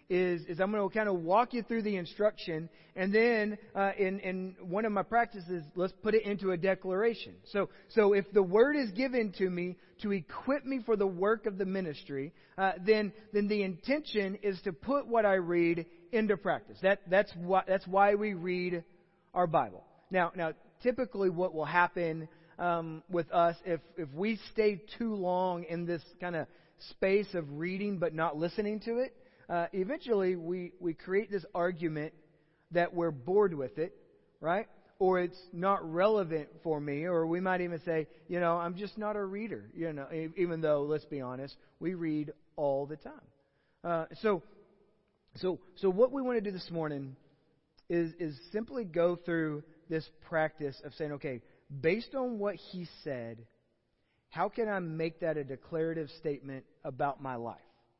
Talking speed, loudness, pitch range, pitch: 180 wpm, -33 LUFS, 160-205 Hz, 180 Hz